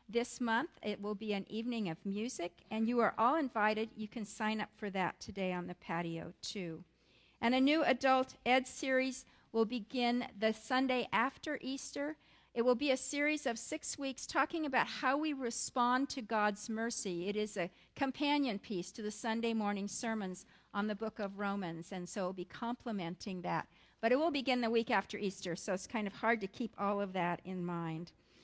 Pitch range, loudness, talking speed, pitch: 200-255 Hz, -36 LUFS, 200 wpm, 225 Hz